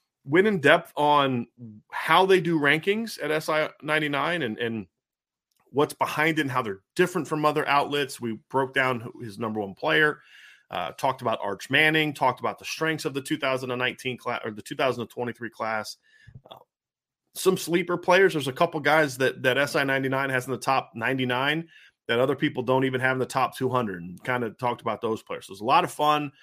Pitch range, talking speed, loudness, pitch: 125-155 Hz, 225 wpm, -25 LUFS, 140 Hz